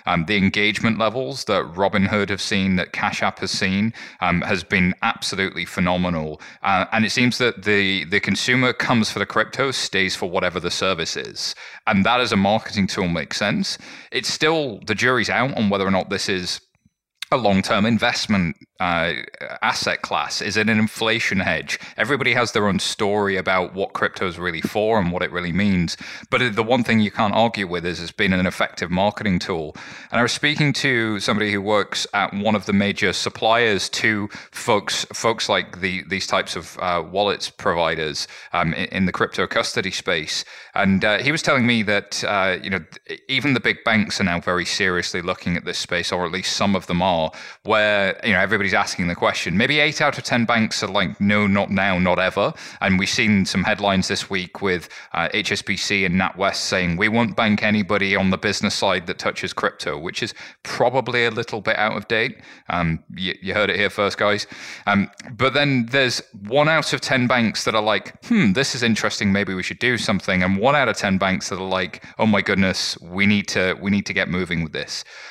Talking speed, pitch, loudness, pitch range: 210 wpm, 105 Hz, -20 LUFS, 95-115 Hz